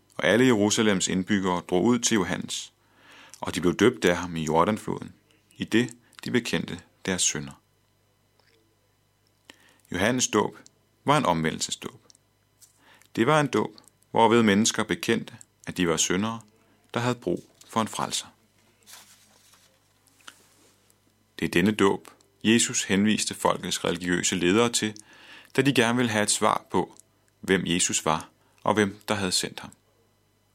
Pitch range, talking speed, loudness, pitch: 95-115 Hz, 140 wpm, -25 LUFS, 105 Hz